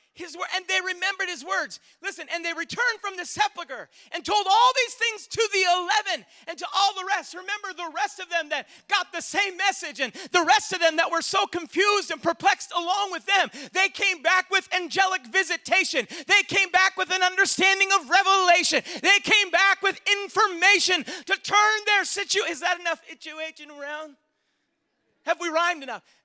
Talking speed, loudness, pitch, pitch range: 190 wpm, -22 LUFS, 370 Hz, 335-395 Hz